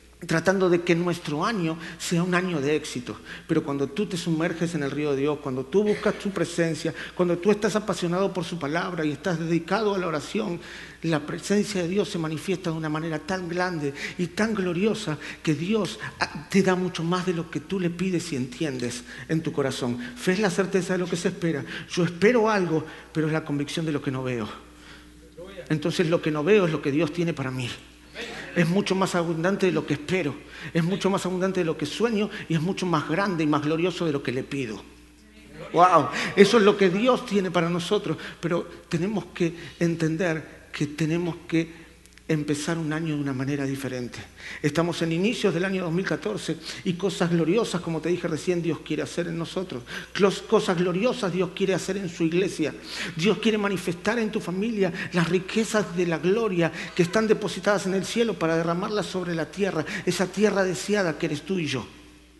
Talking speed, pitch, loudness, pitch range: 200 wpm, 175 Hz, -25 LUFS, 155-190 Hz